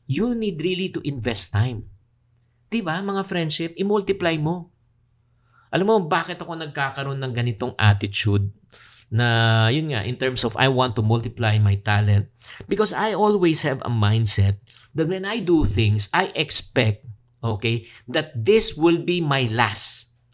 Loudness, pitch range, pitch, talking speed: -21 LUFS, 115-170 Hz, 125 Hz, 150 wpm